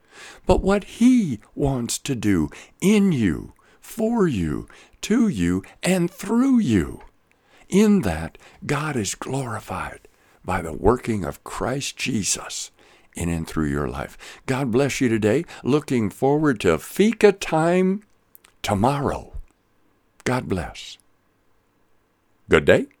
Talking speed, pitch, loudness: 115 wpm, 135 Hz, -22 LUFS